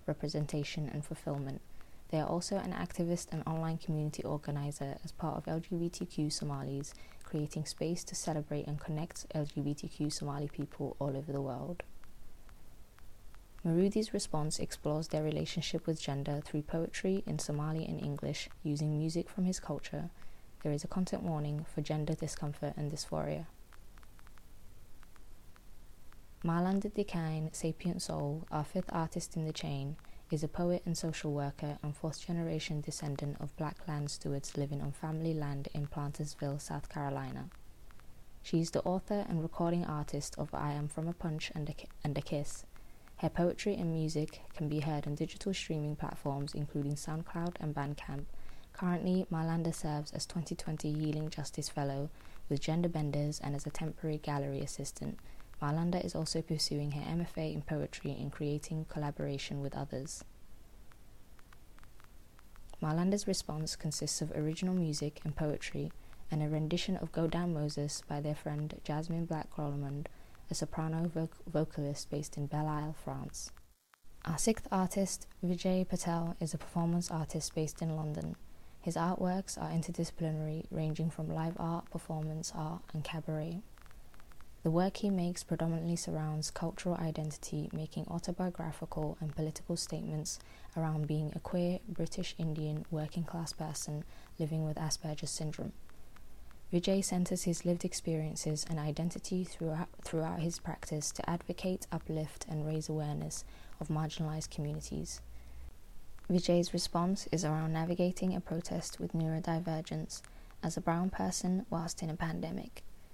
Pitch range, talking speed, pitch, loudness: 150-170 Hz, 145 wpm, 155 Hz, -37 LUFS